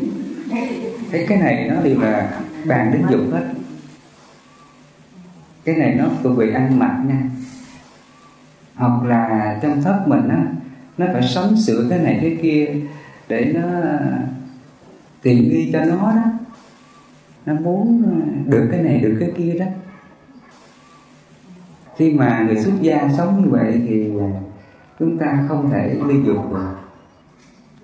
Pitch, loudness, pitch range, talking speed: 150 Hz, -18 LUFS, 130-180 Hz, 140 wpm